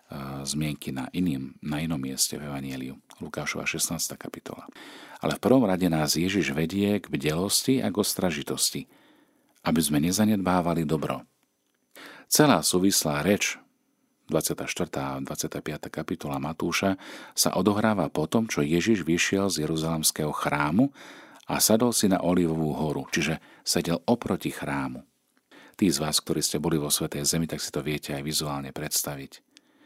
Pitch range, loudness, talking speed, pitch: 75-95 Hz, -26 LUFS, 145 wpm, 80 Hz